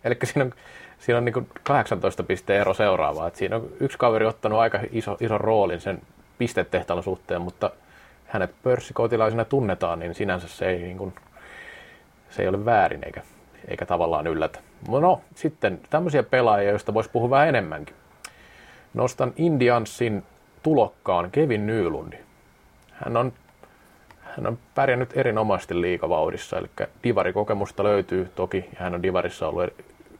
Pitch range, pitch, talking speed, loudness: 100-120 Hz, 110 Hz, 140 wpm, -24 LUFS